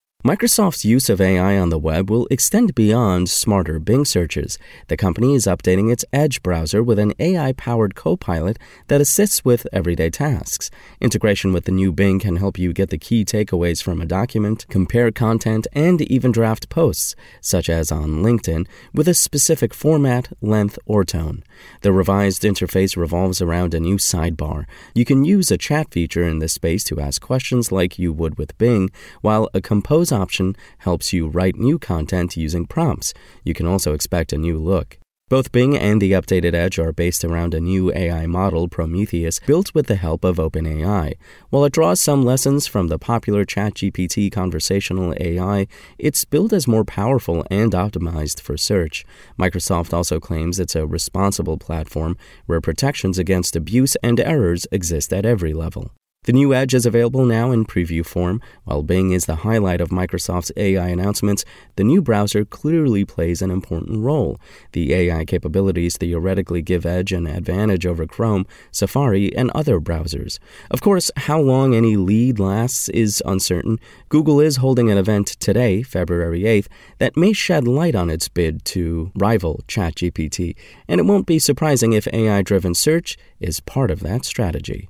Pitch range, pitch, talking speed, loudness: 85-120 Hz, 95 Hz, 170 wpm, -18 LUFS